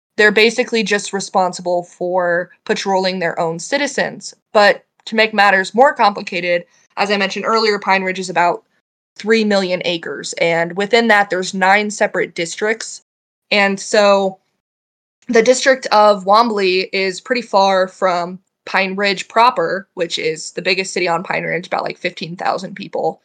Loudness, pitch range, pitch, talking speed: -16 LUFS, 180-210 Hz, 195 Hz, 150 wpm